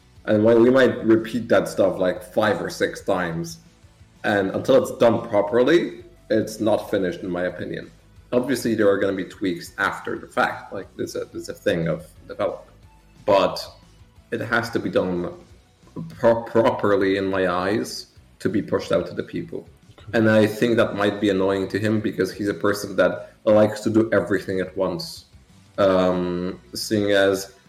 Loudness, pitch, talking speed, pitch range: -22 LUFS, 100 Hz, 180 wpm, 95-110 Hz